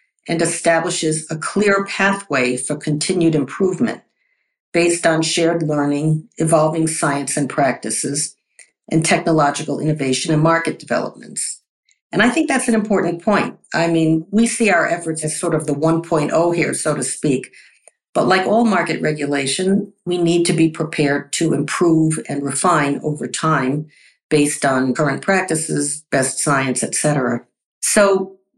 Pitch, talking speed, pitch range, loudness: 160 Hz, 145 wpm, 145-175 Hz, -18 LUFS